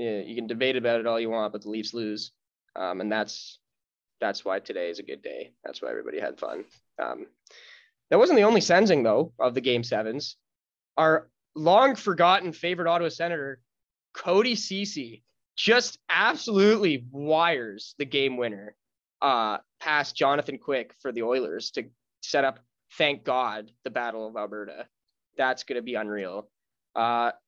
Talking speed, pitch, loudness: 160 wpm, 140 Hz, -26 LUFS